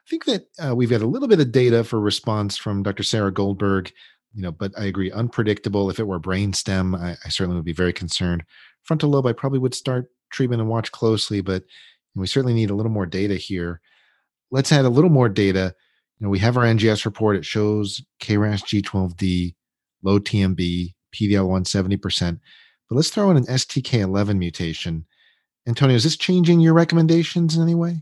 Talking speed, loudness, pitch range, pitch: 195 wpm, -21 LUFS, 95-125 Hz, 105 Hz